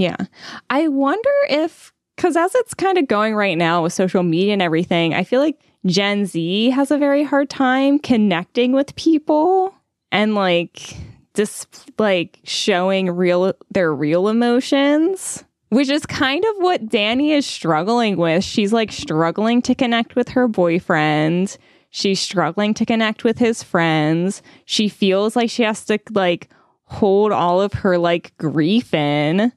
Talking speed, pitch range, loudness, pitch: 160 wpm, 180-265 Hz, -18 LUFS, 215 Hz